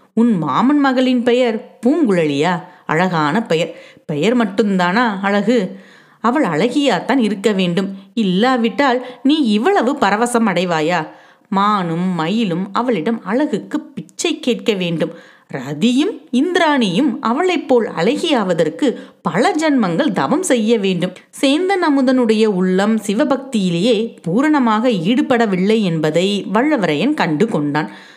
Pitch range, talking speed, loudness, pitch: 190-260 Hz, 100 wpm, -16 LUFS, 230 Hz